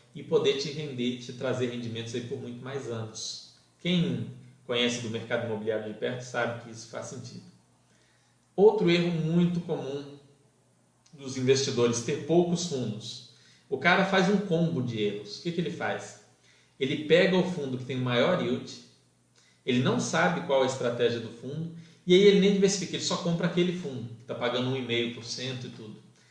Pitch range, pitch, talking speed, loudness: 120-170 Hz, 130 Hz, 180 wpm, -28 LUFS